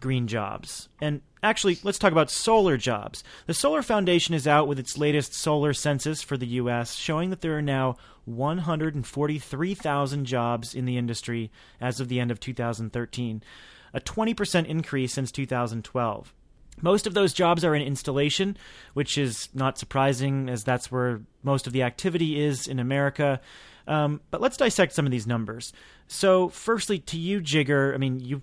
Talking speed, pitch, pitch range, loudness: 170 wpm, 140 Hz, 125-165 Hz, -26 LUFS